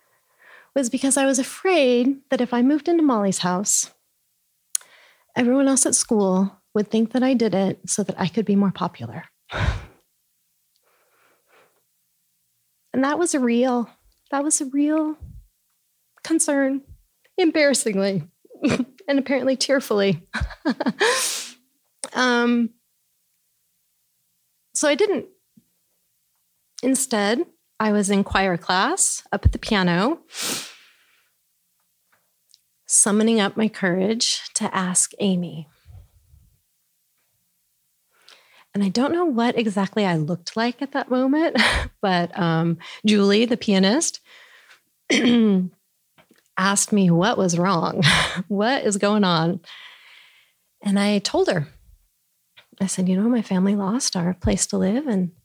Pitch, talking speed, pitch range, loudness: 215 Hz, 115 wpm, 190-270 Hz, -21 LUFS